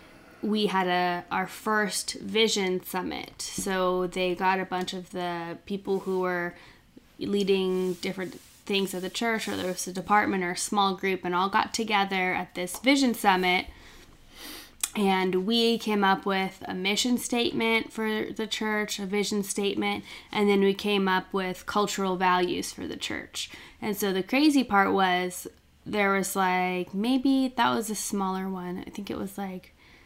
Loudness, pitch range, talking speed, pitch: -27 LUFS, 185-210 Hz, 170 wpm, 195 Hz